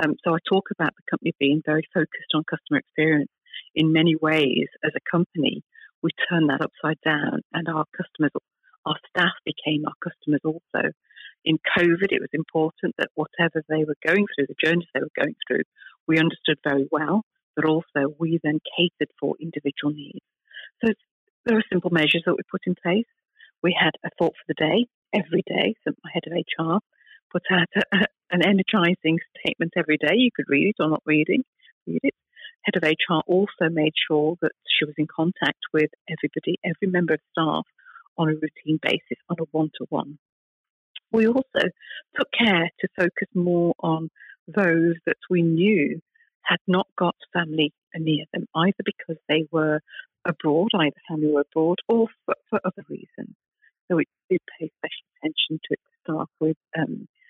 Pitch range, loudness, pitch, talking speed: 155-185 Hz, -24 LUFS, 165 Hz, 175 wpm